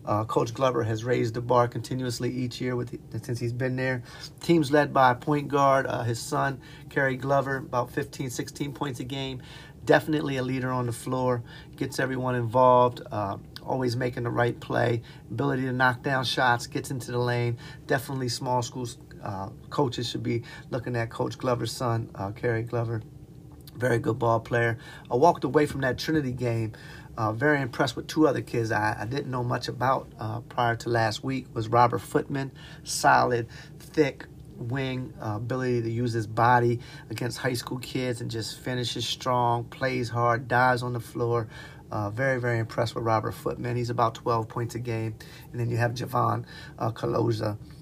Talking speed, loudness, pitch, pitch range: 185 wpm, -27 LUFS, 125 Hz, 120-140 Hz